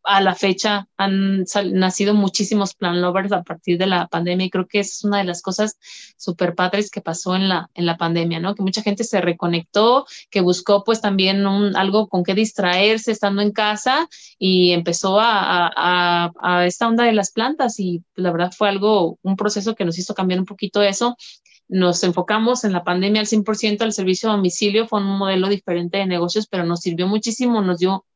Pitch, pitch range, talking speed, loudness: 195 Hz, 180-210 Hz, 205 wpm, -19 LUFS